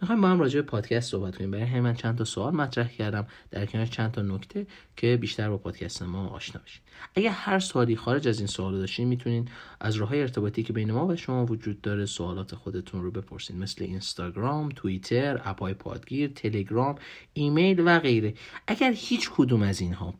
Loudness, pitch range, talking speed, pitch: -28 LUFS, 100-135 Hz, 195 wpm, 115 Hz